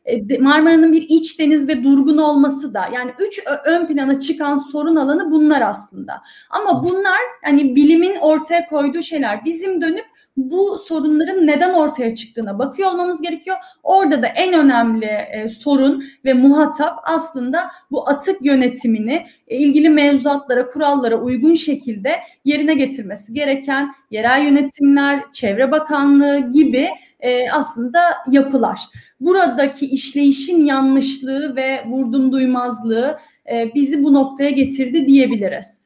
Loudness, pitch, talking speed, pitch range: -16 LUFS, 285 Hz, 125 wpm, 265-315 Hz